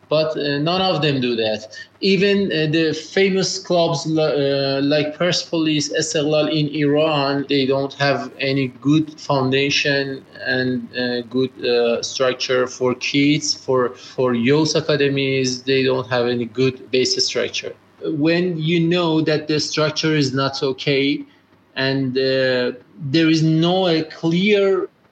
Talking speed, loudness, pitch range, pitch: 140 wpm, -19 LUFS, 130-160 Hz, 145 Hz